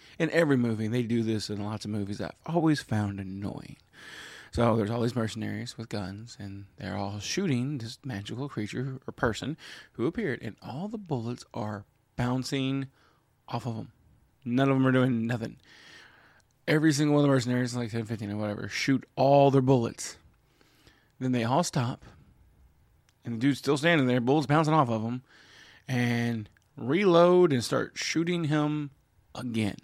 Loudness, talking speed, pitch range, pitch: -28 LUFS, 170 wpm, 110-135 Hz, 120 Hz